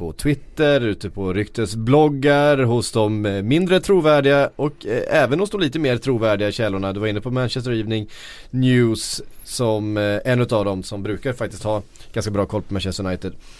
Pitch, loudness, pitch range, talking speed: 110 Hz, -20 LUFS, 105-140 Hz, 175 wpm